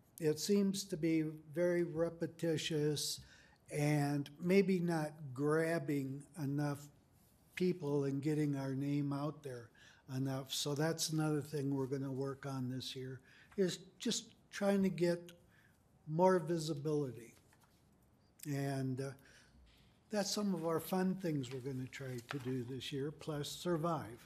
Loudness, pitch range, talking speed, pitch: -38 LUFS, 135-170 Hz, 135 wpm, 150 Hz